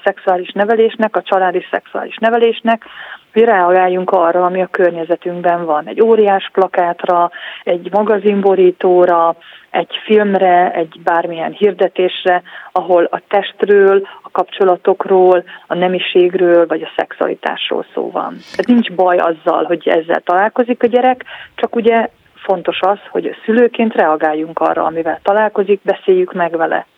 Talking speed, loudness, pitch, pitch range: 125 wpm, -14 LUFS, 185 Hz, 175-215 Hz